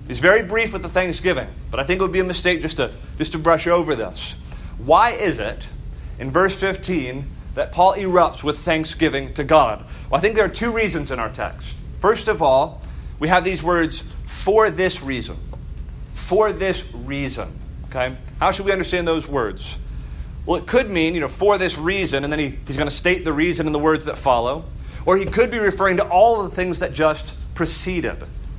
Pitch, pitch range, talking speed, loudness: 165 Hz, 130-185 Hz, 210 wpm, -20 LUFS